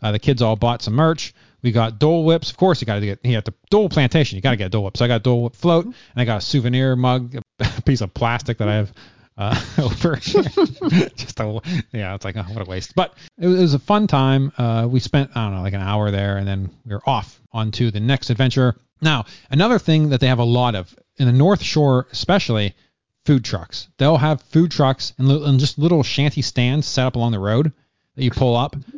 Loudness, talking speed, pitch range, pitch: -19 LUFS, 245 wpm, 110-145 Hz, 125 Hz